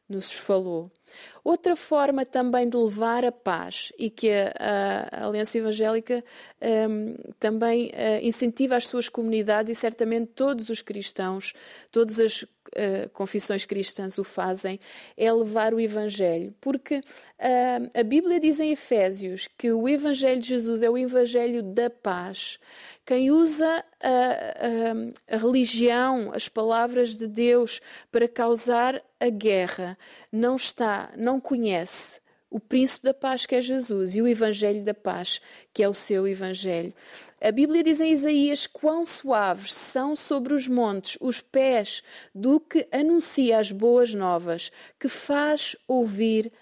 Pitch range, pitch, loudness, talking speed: 210-260 Hz, 235 Hz, -25 LUFS, 145 wpm